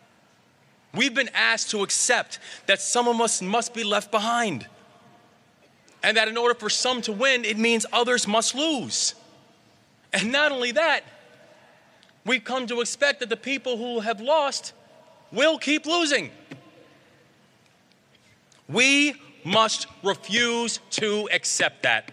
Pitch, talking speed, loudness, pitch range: 235 Hz, 135 wpm, -23 LUFS, 220-260 Hz